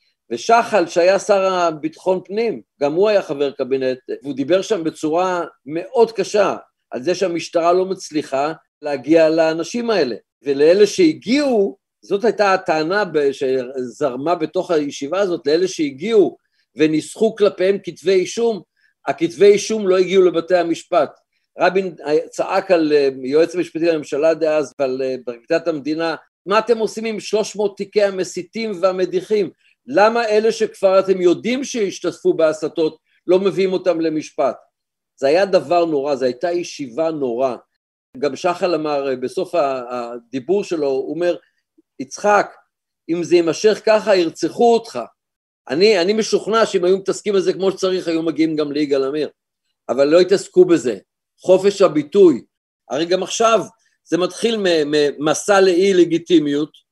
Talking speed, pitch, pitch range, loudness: 130 wpm, 180 Hz, 155-210 Hz, -18 LUFS